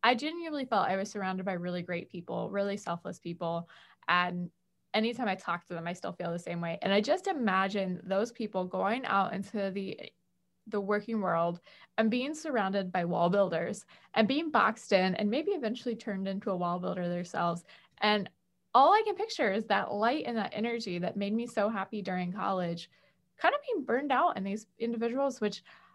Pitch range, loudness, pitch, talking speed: 180-230 Hz, -32 LUFS, 200 Hz, 195 wpm